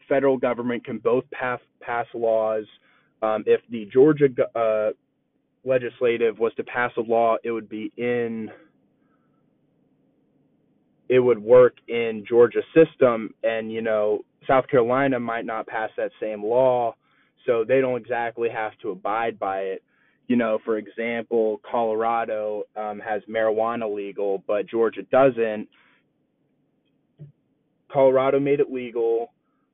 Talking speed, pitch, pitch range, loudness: 130 wpm, 115 Hz, 110-130 Hz, -23 LUFS